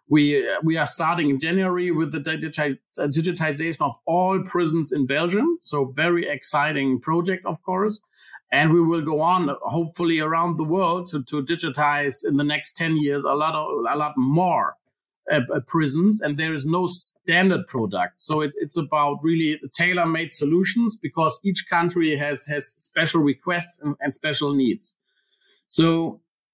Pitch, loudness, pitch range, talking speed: 160 Hz, -22 LUFS, 150-175 Hz, 160 wpm